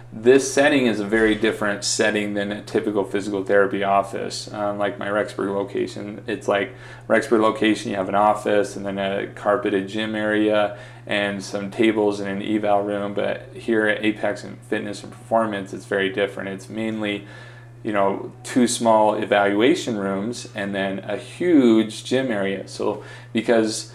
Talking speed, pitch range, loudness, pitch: 165 wpm, 100-115 Hz, -22 LUFS, 105 Hz